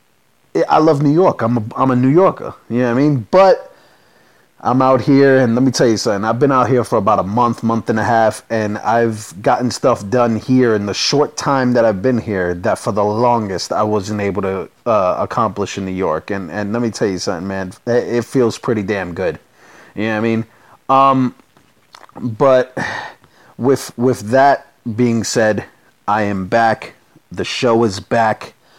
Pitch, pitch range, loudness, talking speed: 115 Hz, 105-125 Hz, -15 LUFS, 200 wpm